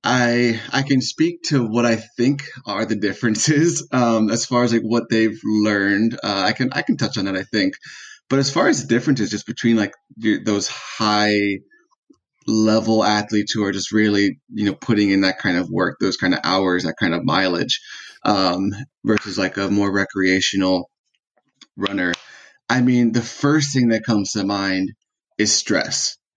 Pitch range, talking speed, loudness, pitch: 100-125 Hz, 180 wpm, -19 LUFS, 110 Hz